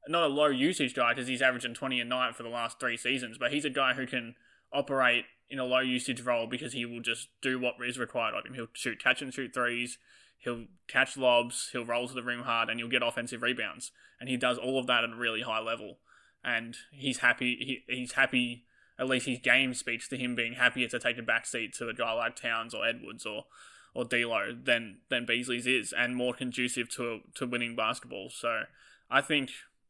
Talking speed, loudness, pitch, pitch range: 225 wpm, -30 LUFS, 125 Hz, 120-130 Hz